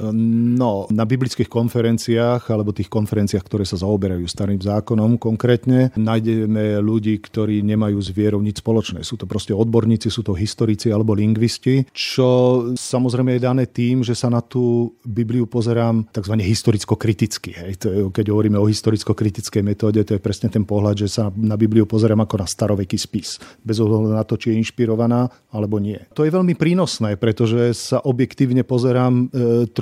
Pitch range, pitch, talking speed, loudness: 105-120 Hz, 110 Hz, 165 wpm, -19 LUFS